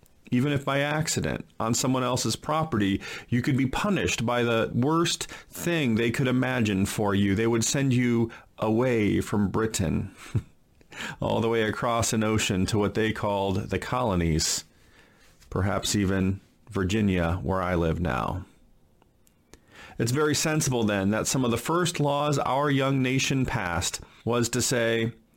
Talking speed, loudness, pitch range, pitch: 150 wpm, -26 LUFS, 100-130 Hz, 115 Hz